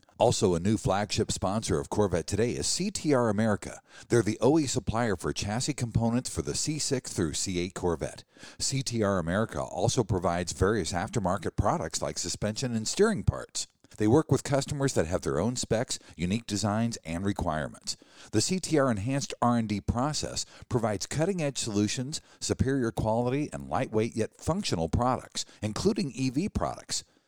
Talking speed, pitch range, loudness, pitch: 145 wpm, 100-130 Hz, -29 LUFS, 110 Hz